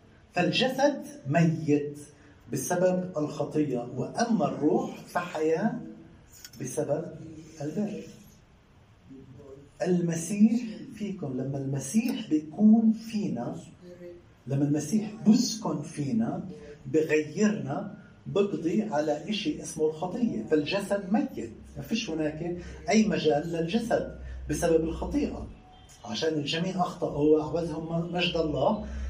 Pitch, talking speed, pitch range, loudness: 160 Hz, 85 wpm, 145-205 Hz, -28 LUFS